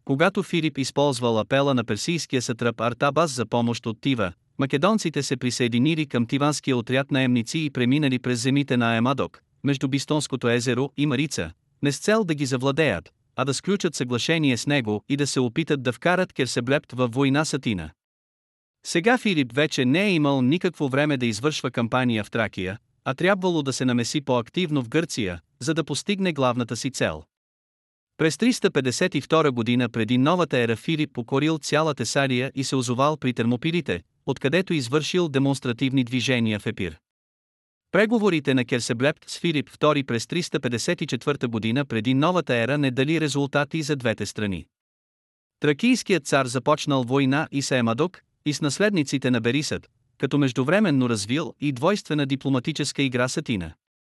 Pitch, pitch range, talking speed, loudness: 135 Hz, 120-150 Hz, 155 wpm, -23 LUFS